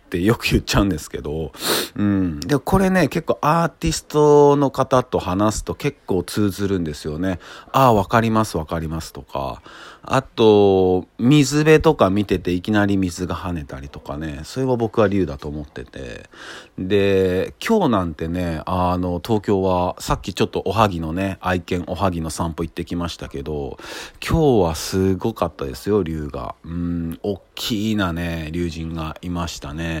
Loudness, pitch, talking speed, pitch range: -20 LUFS, 95 Hz, 325 characters per minute, 85-110 Hz